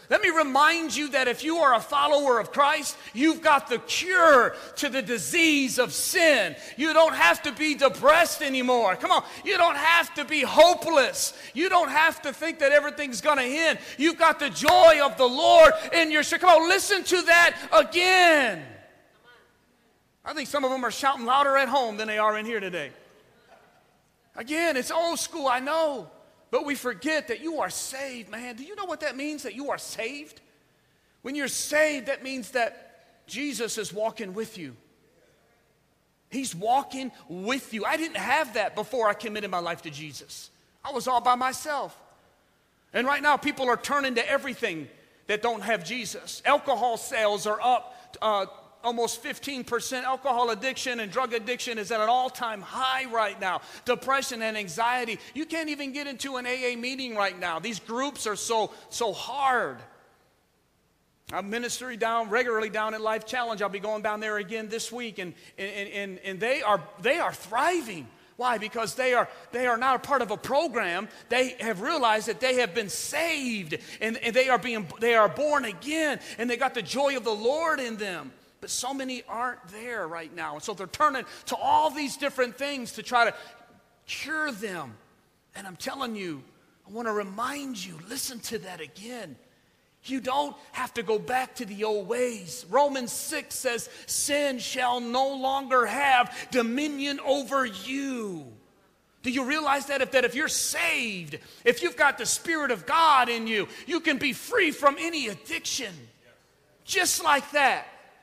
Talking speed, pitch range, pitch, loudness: 180 wpm, 225-295 Hz, 255 Hz, -25 LUFS